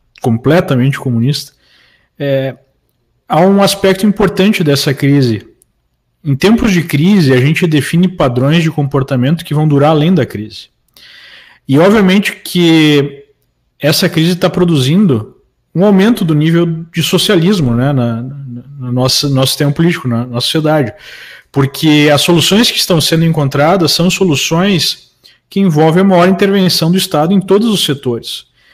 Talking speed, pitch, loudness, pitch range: 145 wpm, 155 Hz, -11 LUFS, 140-185 Hz